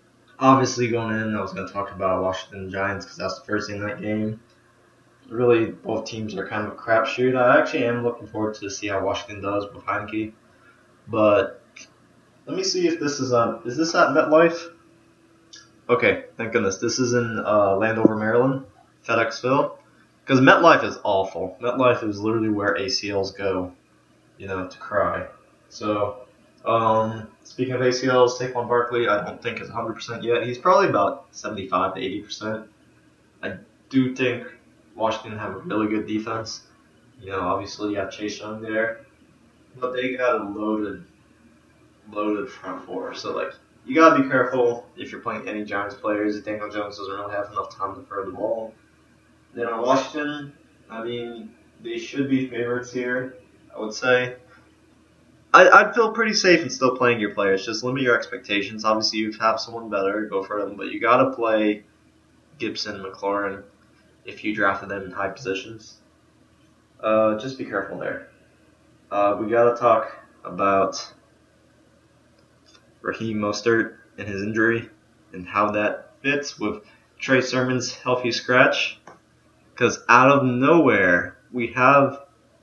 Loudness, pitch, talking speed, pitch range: -22 LUFS, 110 Hz, 160 wpm, 100-125 Hz